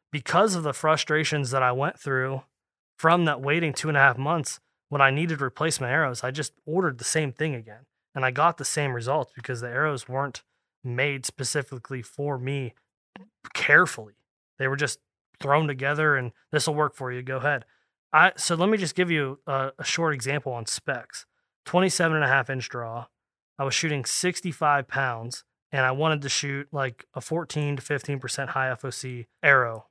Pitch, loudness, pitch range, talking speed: 140 Hz, -25 LUFS, 130-155 Hz, 185 wpm